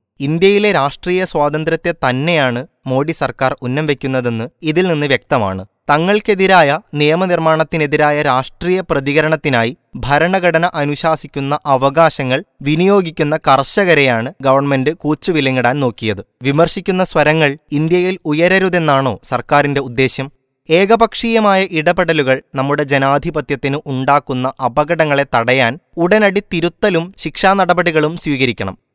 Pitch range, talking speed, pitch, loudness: 135-170 Hz, 80 wpm, 150 Hz, -14 LUFS